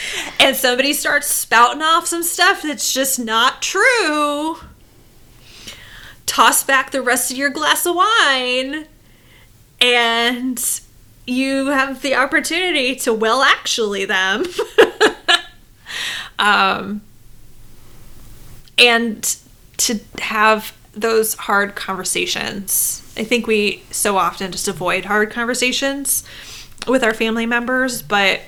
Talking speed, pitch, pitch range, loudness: 105 wpm, 245 Hz, 210-280 Hz, -16 LUFS